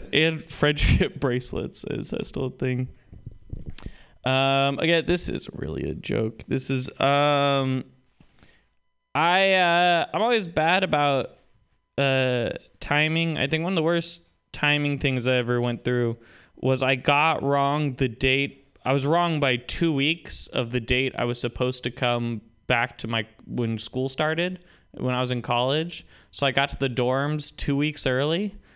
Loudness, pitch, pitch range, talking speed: -24 LUFS, 135 Hz, 125-150 Hz, 165 wpm